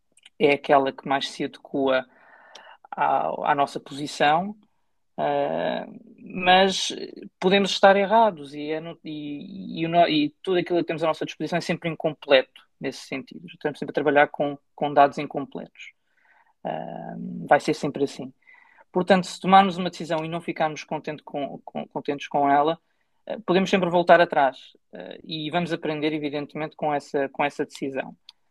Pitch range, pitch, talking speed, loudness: 145-185 Hz, 160 Hz, 160 wpm, -23 LUFS